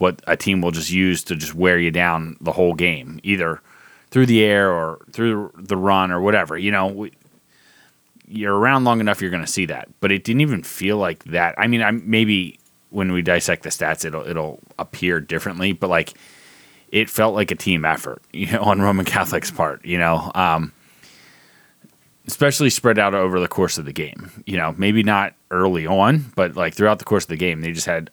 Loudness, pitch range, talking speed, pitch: -19 LUFS, 85-105 Hz, 210 wpm, 95 Hz